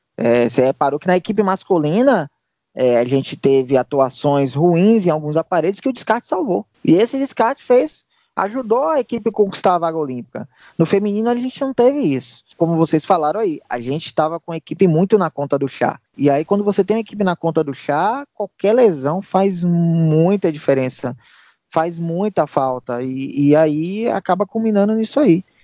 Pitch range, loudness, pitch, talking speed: 140-210 Hz, -17 LUFS, 170 Hz, 185 wpm